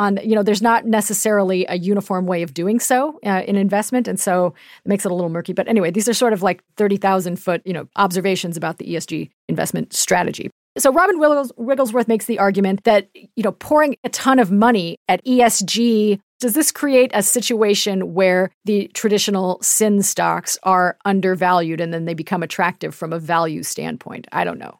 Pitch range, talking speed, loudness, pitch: 185-230 Hz, 195 wpm, -18 LUFS, 200 Hz